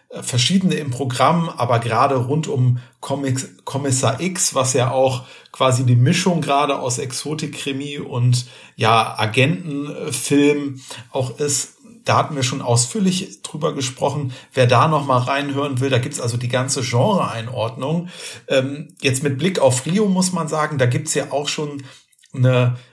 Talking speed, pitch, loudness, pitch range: 150 wpm, 135 Hz, -19 LUFS, 125-150 Hz